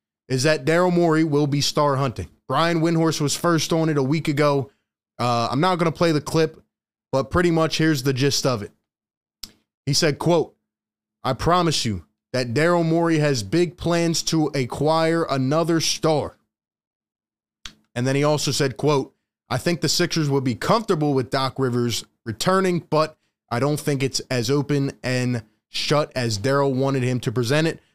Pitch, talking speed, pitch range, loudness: 145 Hz, 175 wpm, 130-160 Hz, -21 LUFS